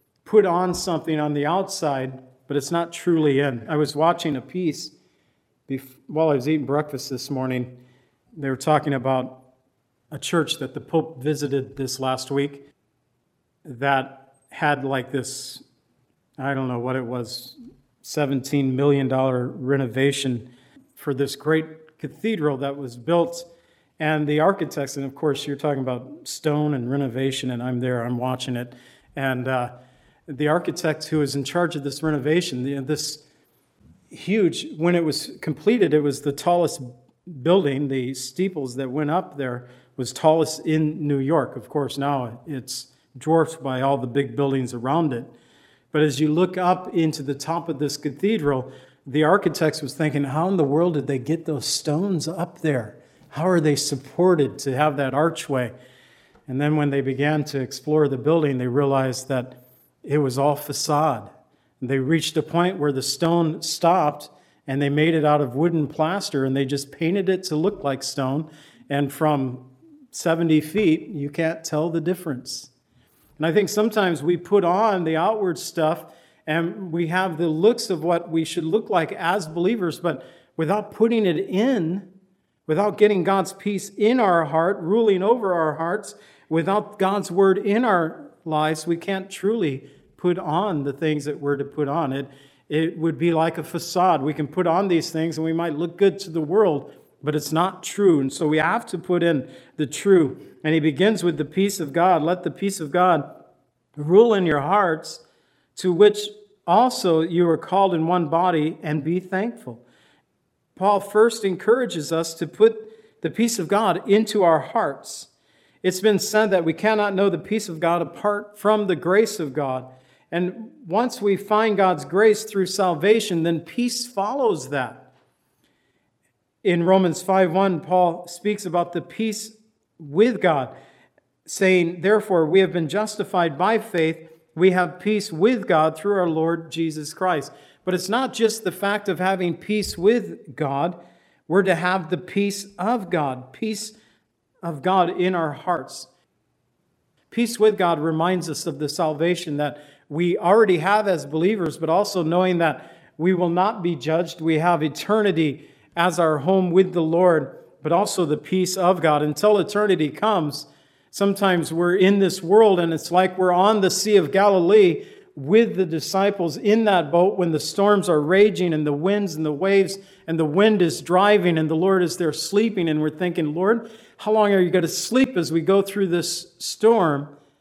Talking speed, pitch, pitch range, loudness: 175 wpm, 165 Hz, 145-190 Hz, -22 LUFS